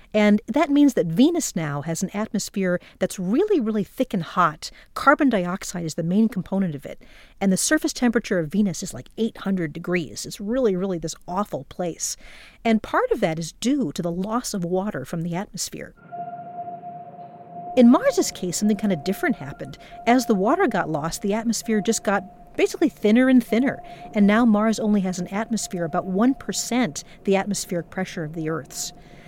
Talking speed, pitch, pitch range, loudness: 180 wpm, 200 Hz, 175-235 Hz, -23 LUFS